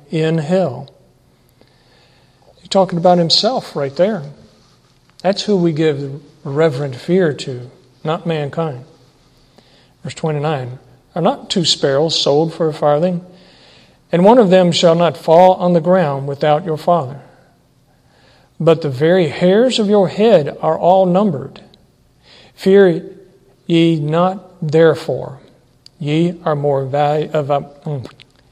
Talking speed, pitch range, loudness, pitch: 125 wpm, 145-180 Hz, -15 LUFS, 160 Hz